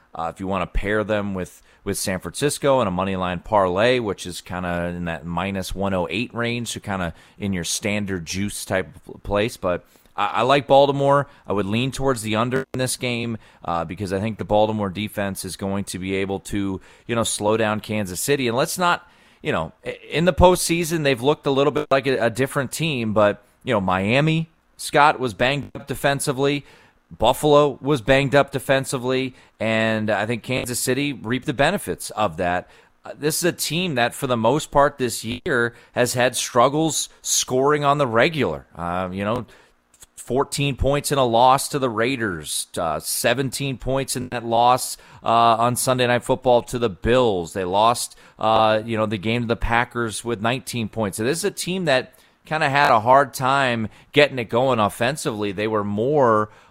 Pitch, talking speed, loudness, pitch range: 120 Hz, 195 wpm, -21 LUFS, 105-140 Hz